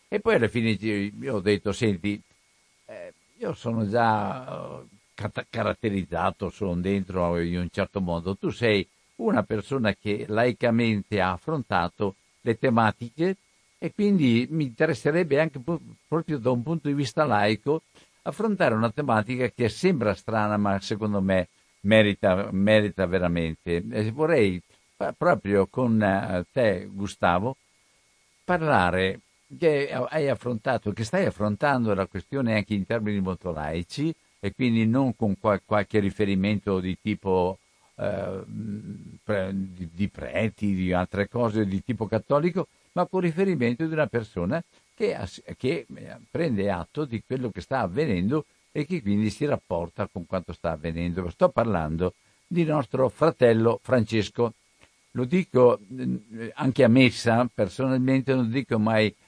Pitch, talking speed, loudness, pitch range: 110 Hz, 130 wpm, -26 LUFS, 95-130 Hz